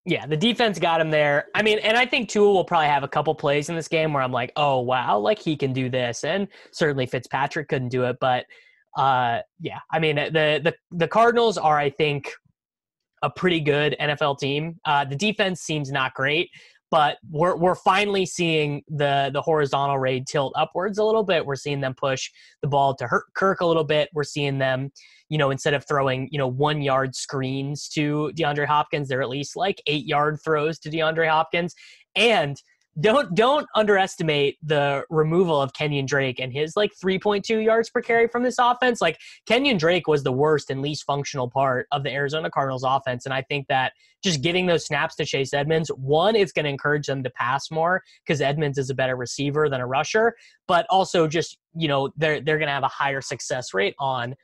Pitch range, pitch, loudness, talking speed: 140-170 Hz, 150 Hz, -22 LUFS, 210 wpm